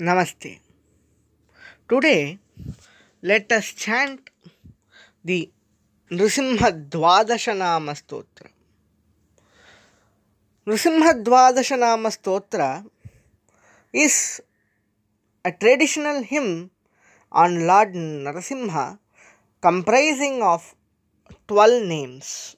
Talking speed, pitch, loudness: 55 wpm, 180 Hz, -20 LUFS